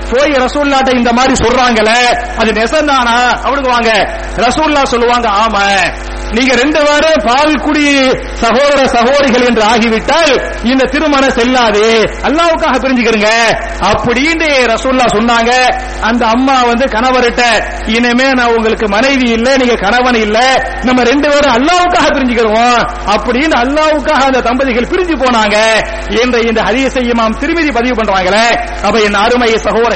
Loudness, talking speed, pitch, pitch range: -9 LUFS, 115 wpm, 245 Hz, 230-270 Hz